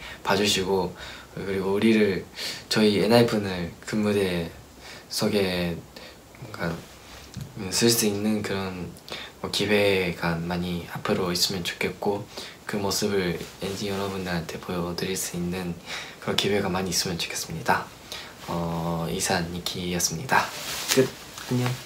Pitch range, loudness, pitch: 90-105 Hz, -26 LUFS, 95 Hz